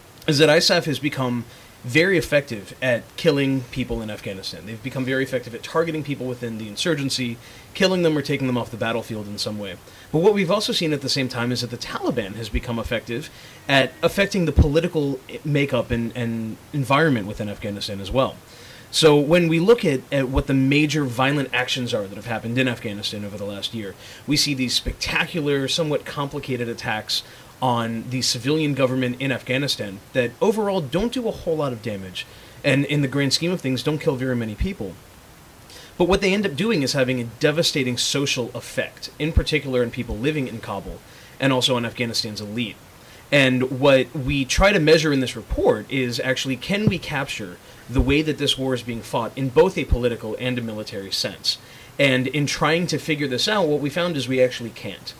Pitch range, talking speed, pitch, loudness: 115-145 Hz, 200 wpm, 130 Hz, -22 LUFS